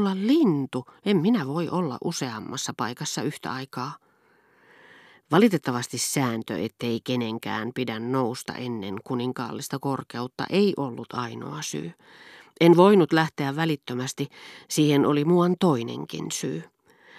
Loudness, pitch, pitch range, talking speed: -25 LUFS, 140 Hz, 125-170 Hz, 110 wpm